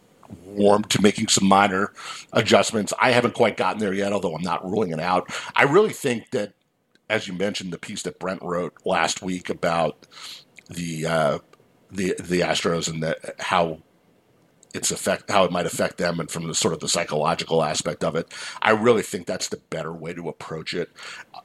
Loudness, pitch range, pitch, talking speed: -23 LUFS, 80-100 Hz, 85 Hz, 190 wpm